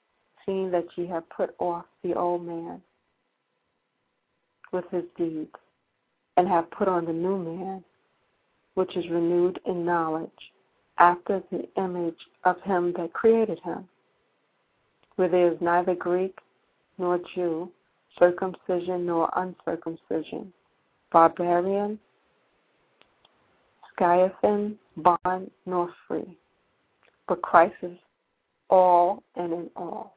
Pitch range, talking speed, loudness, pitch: 170-185 Hz, 110 wpm, -26 LUFS, 175 Hz